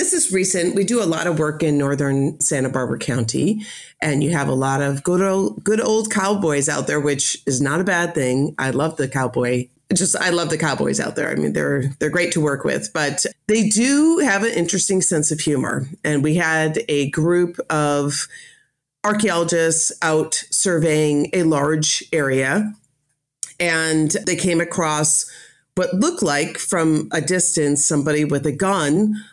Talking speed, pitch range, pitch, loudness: 180 wpm, 145-185 Hz, 160 Hz, -19 LUFS